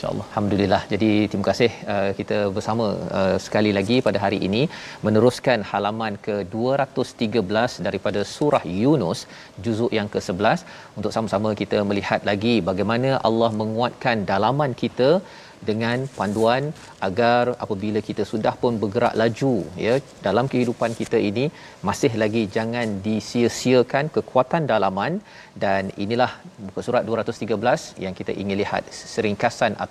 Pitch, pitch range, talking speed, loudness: 110 Hz, 105-120 Hz, 120 wpm, -22 LUFS